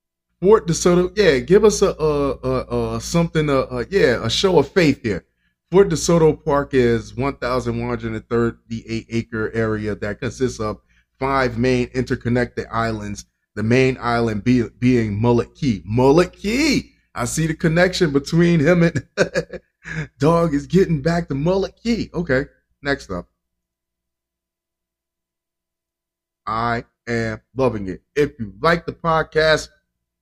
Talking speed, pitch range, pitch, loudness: 135 wpm, 115-165 Hz, 130 Hz, -19 LUFS